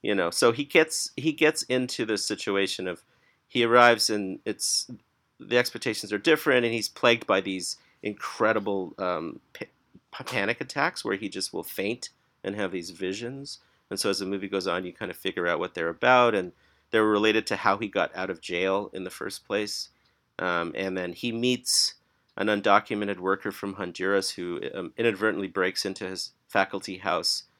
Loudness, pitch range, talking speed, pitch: -26 LUFS, 95-120 Hz, 185 wpm, 105 Hz